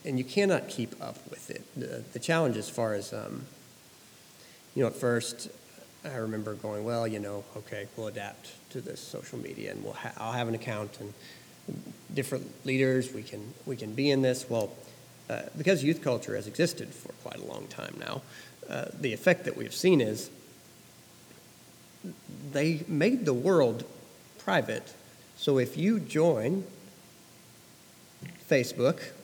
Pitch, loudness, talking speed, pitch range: 125 Hz, -31 LUFS, 160 wpm, 110-150 Hz